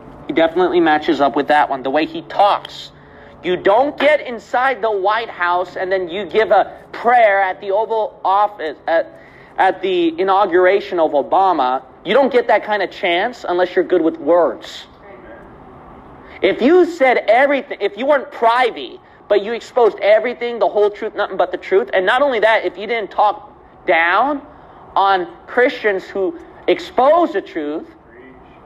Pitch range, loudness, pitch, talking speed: 185-290 Hz, -16 LUFS, 220 Hz, 170 wpm